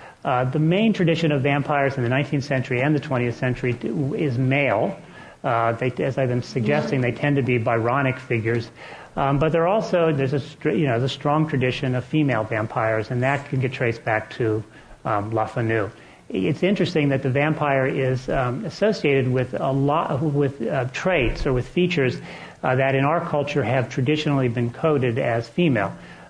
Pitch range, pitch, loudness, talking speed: 125-145 Hz, 135 Hz, -22 LUFS, 190 wpm